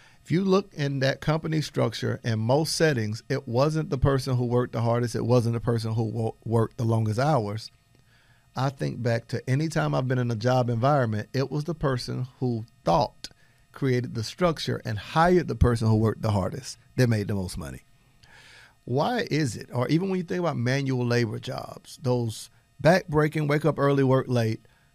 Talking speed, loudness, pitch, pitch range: 190 wpm, -26 LUFS, 125 Hz, 115-140 Hz